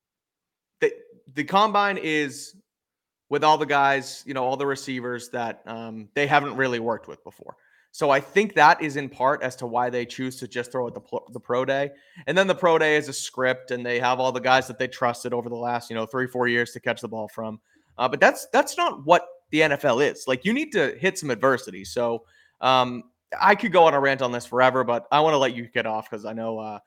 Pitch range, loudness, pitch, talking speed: 120-150 Hz, -23 LUFS, 130 Hz, 245 wpm